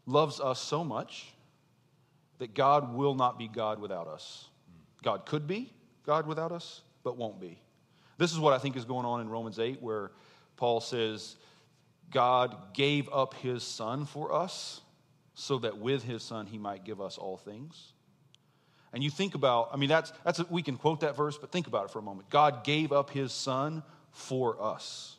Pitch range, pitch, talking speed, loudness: 120-150 Hz, 140 Hz, 185 wpm, -32 LUFS